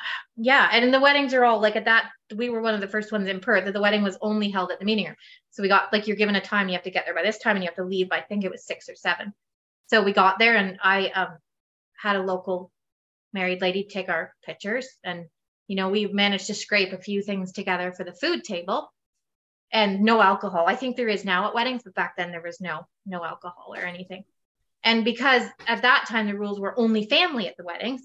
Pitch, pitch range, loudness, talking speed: 205 Hz, 185-225 Hz, -23 LUFS, 260 wpm